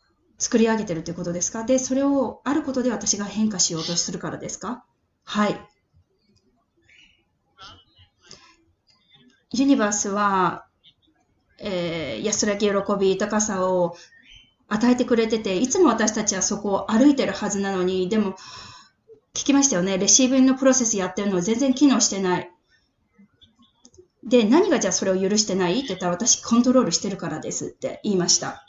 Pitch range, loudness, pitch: 185-245 Hz, -21 LUFS, 205 Hz